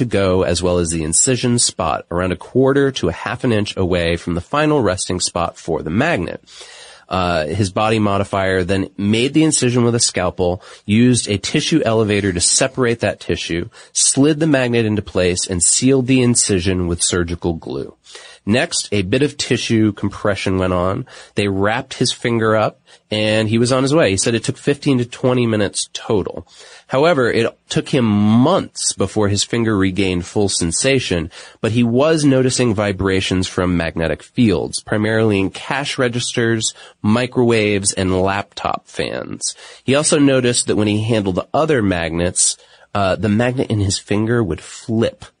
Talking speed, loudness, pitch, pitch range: 170 wpm, -17 LUFS, 105 Hz, 95-125 Hz